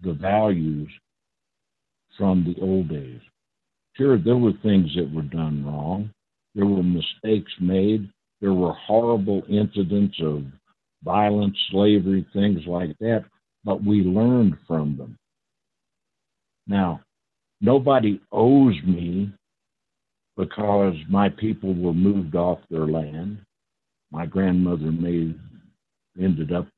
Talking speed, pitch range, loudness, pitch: 110 wpm, 85-105 Hz, -22 LUFS, 95 Hz